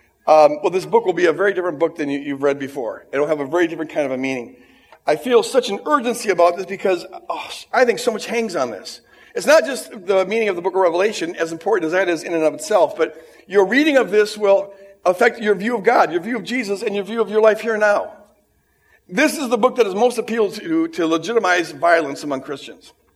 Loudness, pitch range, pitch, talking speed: -18 LUFS, 165-230 Hz, 195 Hz, 255 wpm